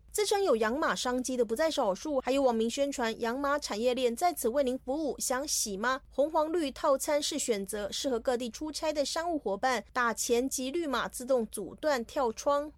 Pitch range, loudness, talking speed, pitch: 235-290 Hz, -30 LUFS, 290 characters per minute, 260 Hz